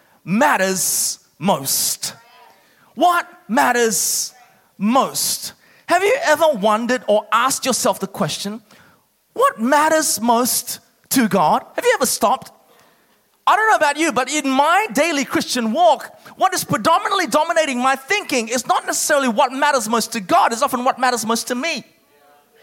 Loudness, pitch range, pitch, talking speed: -17 LUFS, 230-315 Hz, 265 Hz, 145 wpm